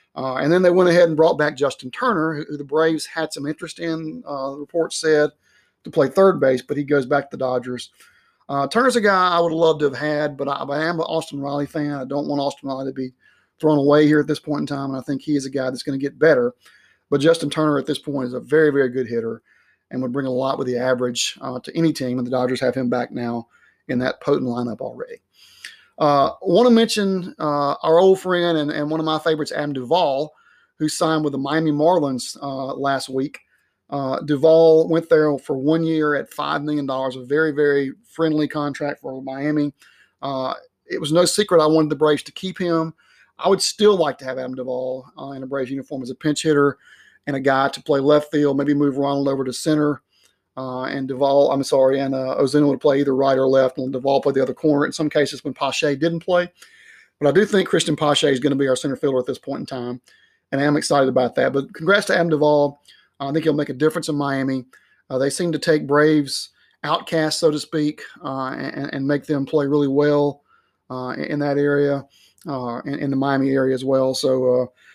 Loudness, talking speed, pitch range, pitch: -20 LUFS, 235 wpm, 135-155 Hz, 145 Hz